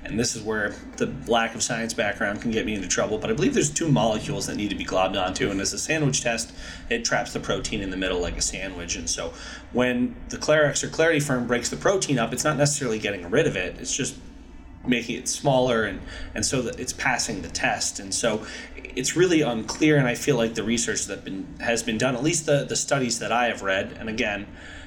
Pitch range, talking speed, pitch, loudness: 115-145 Hz, 240 wpm, 125 Hz, -24 LUFS